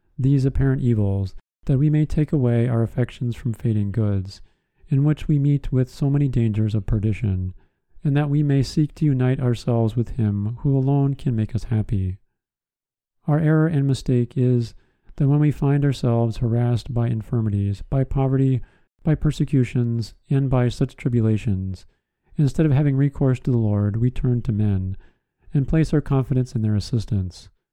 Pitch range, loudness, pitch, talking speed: 110-140 Hz, -22 LUFS, 125 Hz, 170 wpm